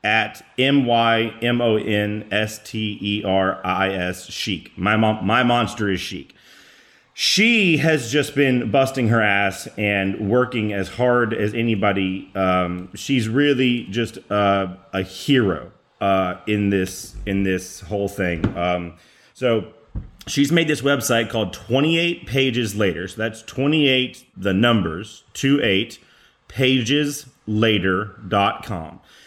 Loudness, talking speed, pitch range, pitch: -20 LUFS, 110 wpm, 95-125 Hz, 110 Hz